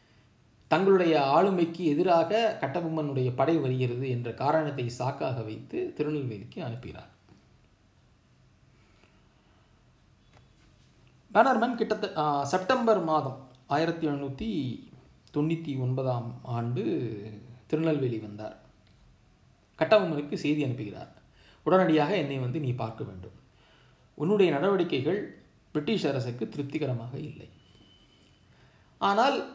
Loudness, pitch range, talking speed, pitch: -28 LUFS, 120-165 Hz, 80 wpm, 140 Hz